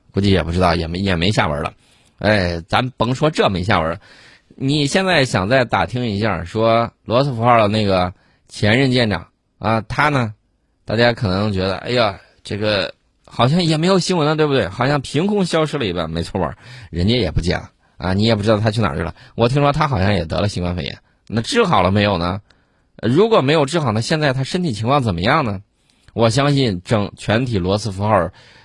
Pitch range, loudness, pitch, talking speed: 95-130 Hz, -18 LUFS, 110 Hz, 300 characters per minute